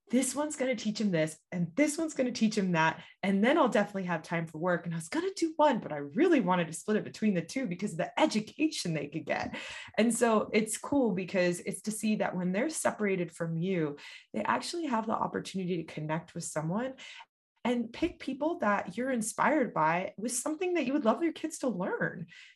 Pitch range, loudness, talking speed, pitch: 180-270 Hz, -31 LUFS, 230 wpm, 215 Hz